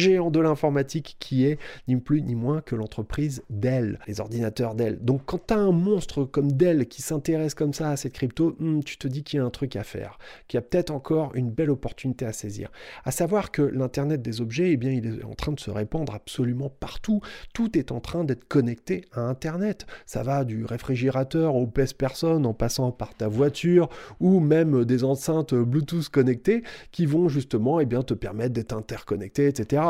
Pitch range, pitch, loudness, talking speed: 120-160 Hz, 140 Hz, -25 LUFS, 210 wpm